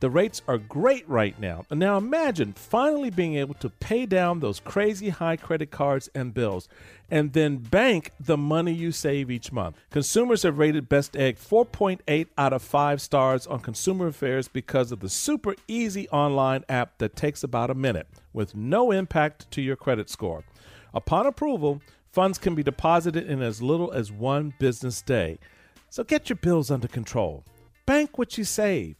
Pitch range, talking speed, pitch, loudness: 125-185 Hz, 180 wpm, 145 Hz, -25 LUFS